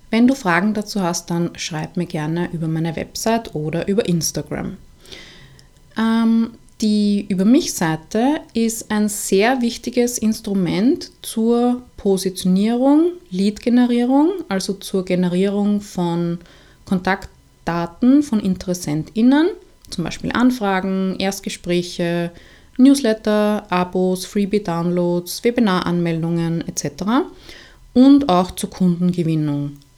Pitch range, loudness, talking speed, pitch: 175-230 Hz, -19 LUFS, 90 wpm, 195 Hz